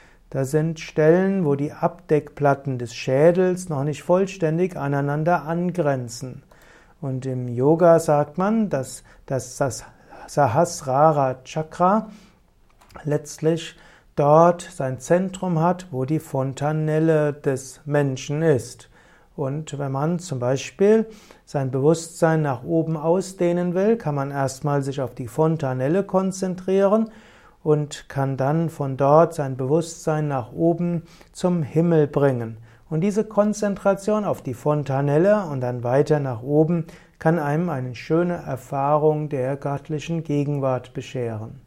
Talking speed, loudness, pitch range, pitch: 120 wpm, -22 LUFS, 135-170 Hz, 150 Hz